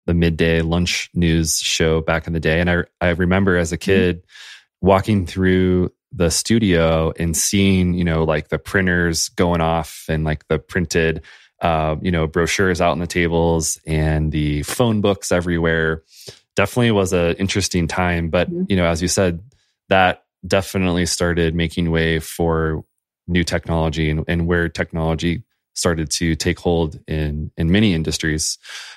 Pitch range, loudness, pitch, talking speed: 80-90 Hz, -19 LUFS, 85 Hz, 160 wpm